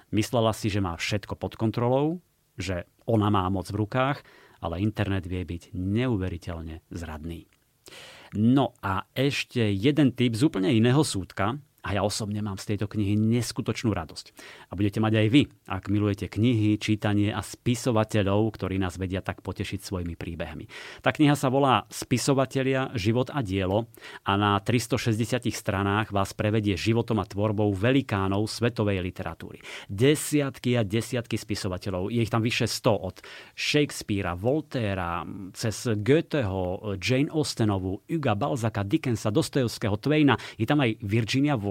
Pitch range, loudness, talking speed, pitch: 100-125 Hz, -26 LUFS, 145 wpm, 110 Hz